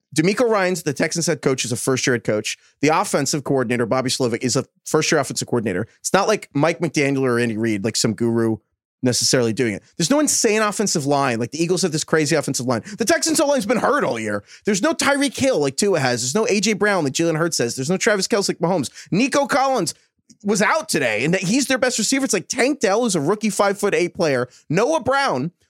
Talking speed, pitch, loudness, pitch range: 240 wpm, 170 Hz, -19 LUFS, 130-215 Hz